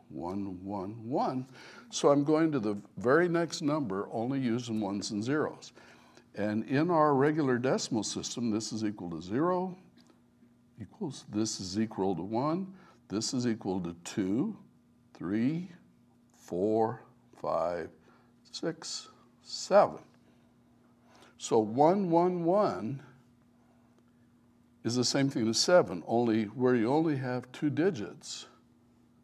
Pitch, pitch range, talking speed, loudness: 120 Hz, 110-145 Hz, 125 wpm, -31 LUFS